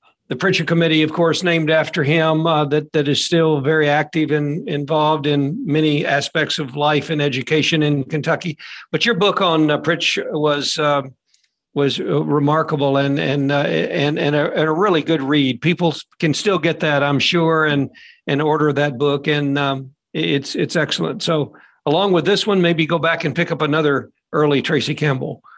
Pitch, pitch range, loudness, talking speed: 150 Hz, 145-160 Hz, -18 LUFS, 190 wpm